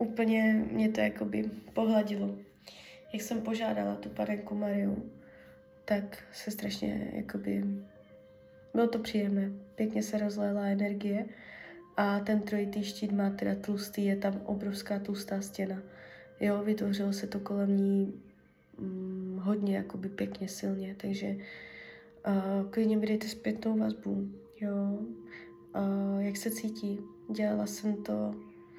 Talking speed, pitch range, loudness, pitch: 125 wpm, 185-210 Hz, -33 LUFS, 200 Hz